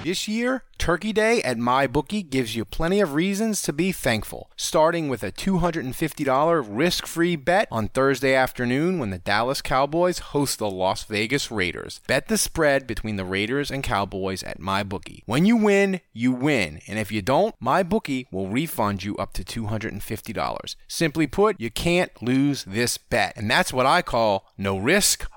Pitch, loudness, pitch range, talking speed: 135 Hz, -23 LUFS, 110-175 Hz, 175 wpm